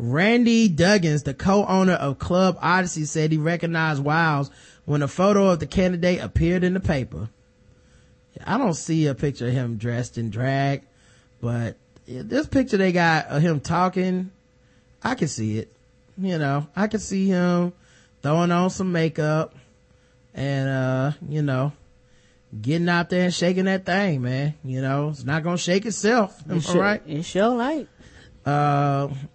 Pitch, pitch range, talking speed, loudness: 160 Hz, 130-185 Hz, 165 wpm, -22 LUFS